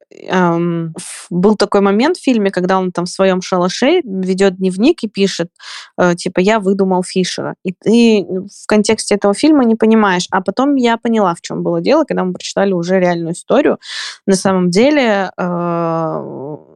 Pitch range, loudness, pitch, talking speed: 180-220 Hz, -14 LUFS, 195 Hz, 160 wpm